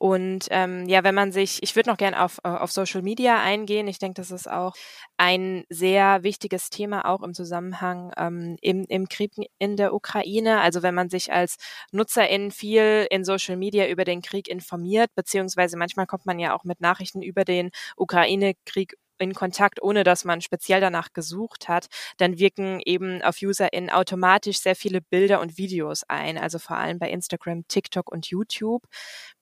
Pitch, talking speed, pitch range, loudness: 190 Hz, 180 wpm, 180-200 Hz, -24 LUFS